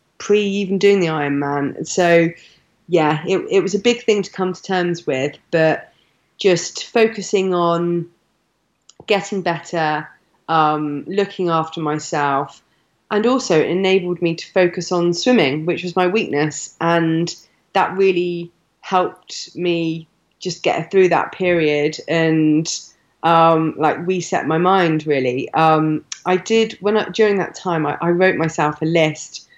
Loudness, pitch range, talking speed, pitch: -18 LUFS, 155-185 Hz, 150 wpm, 170 Hz